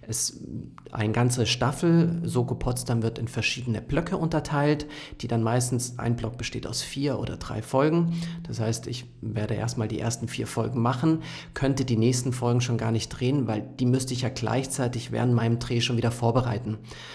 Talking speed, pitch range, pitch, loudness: 185 wpm, 115-135 Hz, 120 Hz, -27 LUFS